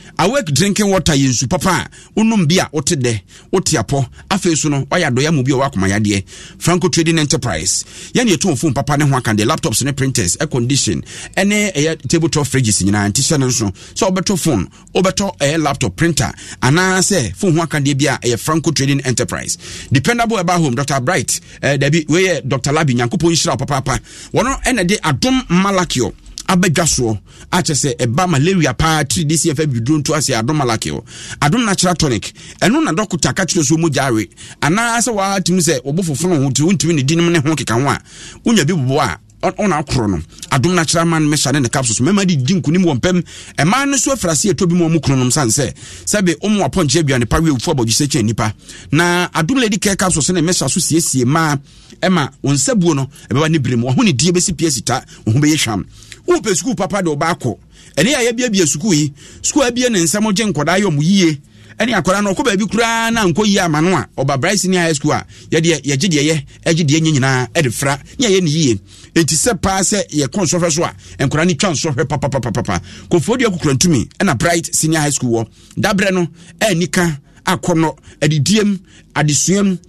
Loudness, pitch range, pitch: -15 LUFS, 135-180 Hz, 160 Hz